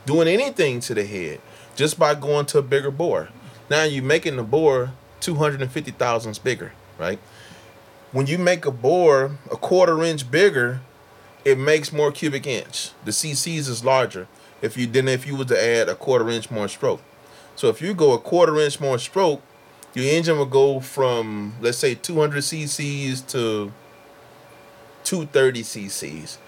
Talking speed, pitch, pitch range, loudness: 165 wpm, 140 Hz, 120-155 Hz, -21 LUFS